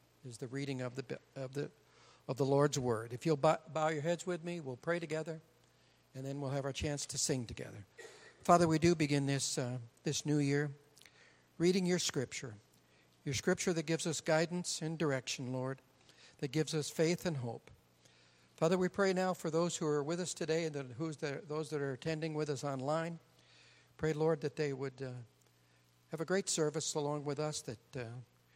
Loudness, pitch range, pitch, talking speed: -36 LUFS, 130-160 Hz, 150 Hz, 200 wpm